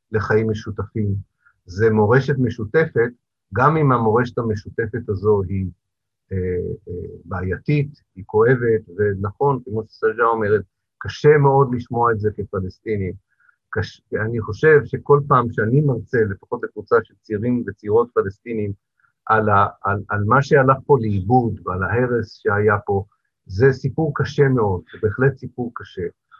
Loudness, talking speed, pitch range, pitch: -20 LUFS, 135 wpm, 105-135 Hz, 115 Hz